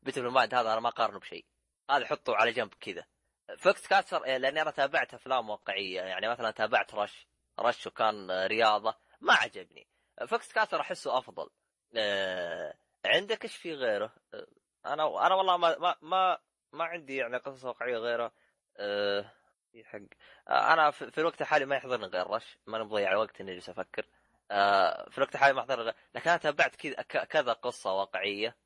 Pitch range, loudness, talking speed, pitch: 105-155 Hz, -30 LUFS, 165 wpm, 125 Hz